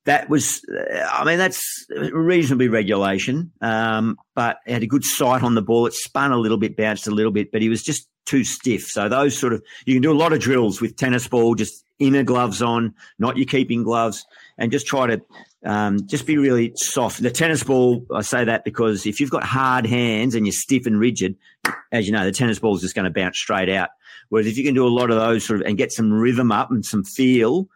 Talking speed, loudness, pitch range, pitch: 240 wpm, -20 LUFS, 110-130 Hz, 120 Hz